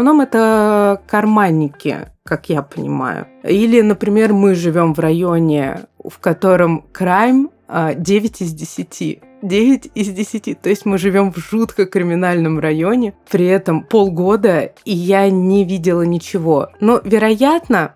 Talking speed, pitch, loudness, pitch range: 130 wpm, 195 Hz, -15 LUFS, 170-220 Hz